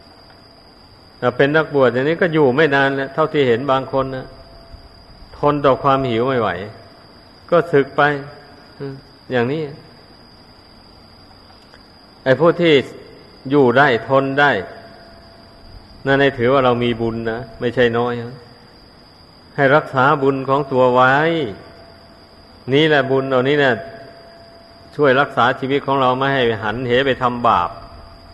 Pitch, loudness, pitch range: 130 Hz, -16 LUFS, 110-140 Hz